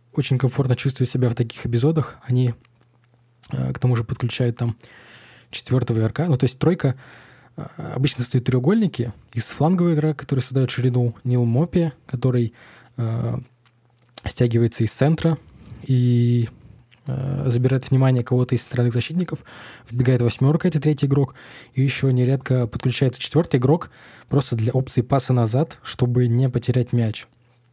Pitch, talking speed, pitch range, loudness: 125 Hz, 135 wpm, 120-135 Hz, -21 LUFS